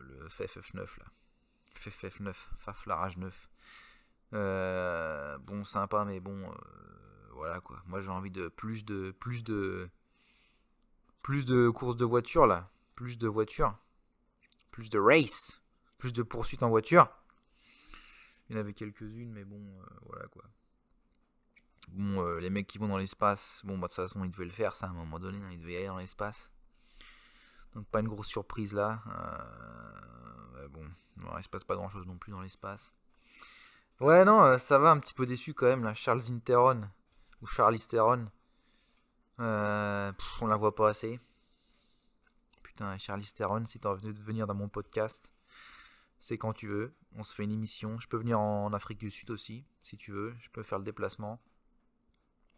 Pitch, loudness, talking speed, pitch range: 105 Hz, -31 LUFS, 175 wpm, 95-115 Hz